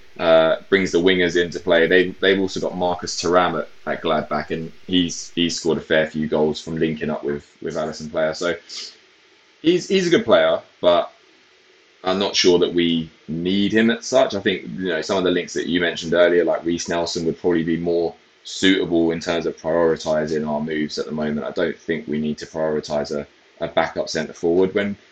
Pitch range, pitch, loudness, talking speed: 80-95 Hz, 85 Hz, -20 LUFS, 210 wpm